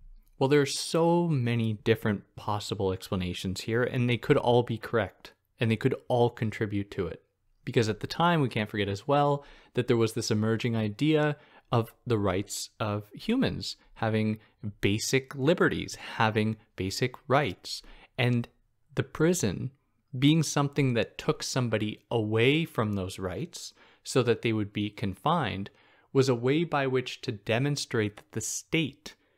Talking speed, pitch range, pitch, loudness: 155 wpm, 105-140 Hz, 115 Hz, -29 LUFS